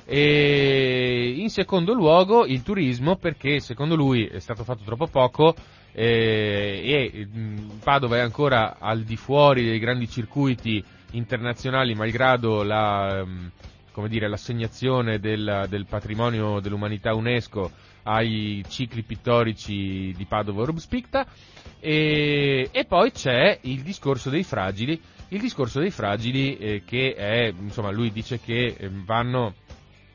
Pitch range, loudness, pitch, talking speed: 105-135 Hz, -23 LUFS, 115 Hz, 120 wpm